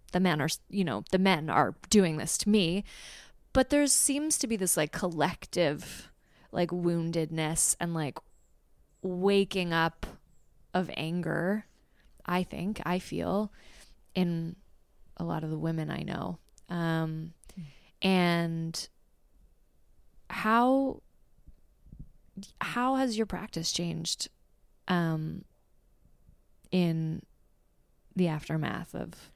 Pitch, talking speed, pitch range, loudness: 170 Hz, 110 wpm, 160-190 Hz, -30 LUFS